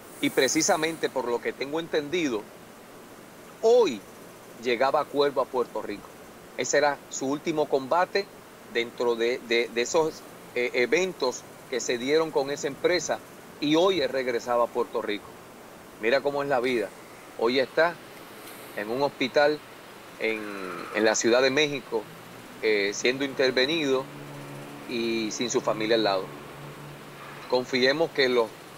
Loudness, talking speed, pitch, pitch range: -26 LUFS, 140 wpm, 135 Hz, 115-160 Hz